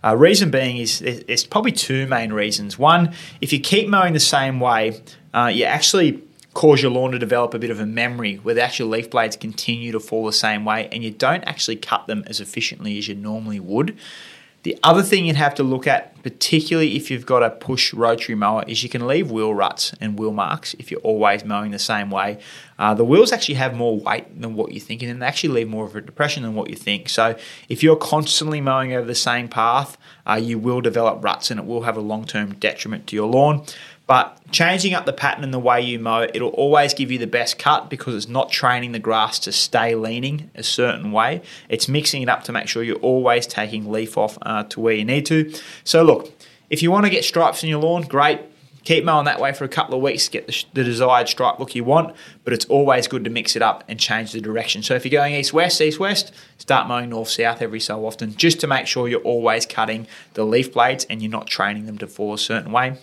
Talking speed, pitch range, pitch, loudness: 245 wpm, 110-145 Hz, 120 Hz, -19 LUFS